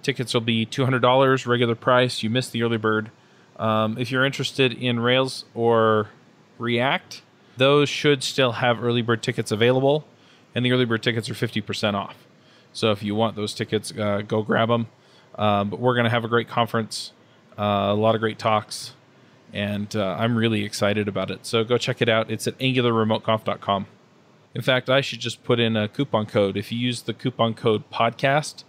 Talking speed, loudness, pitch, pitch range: 200 wpm, -22 LUFS, 115 Hz, 110-125 Hz